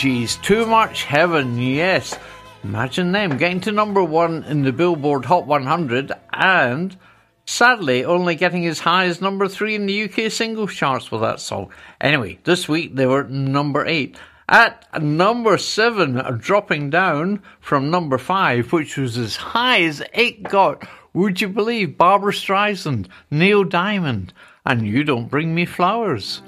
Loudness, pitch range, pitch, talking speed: -18 LUFS, 140-195 Hz, 175 Hz, 155 wpm